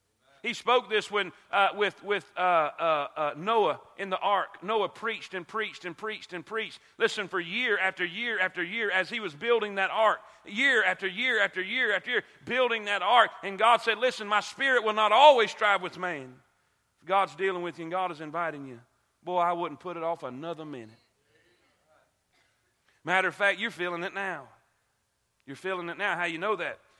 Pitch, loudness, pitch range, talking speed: 195 Hz, -27 LUFS, 175-215 Hz, 200 wpm